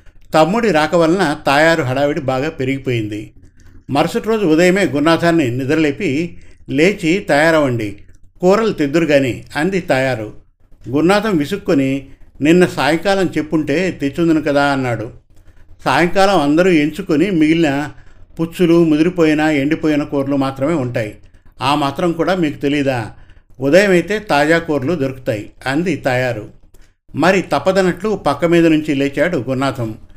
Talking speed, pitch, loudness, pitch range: 110 wpm, 145 Hz, -15 LUFS, 125-165 Hz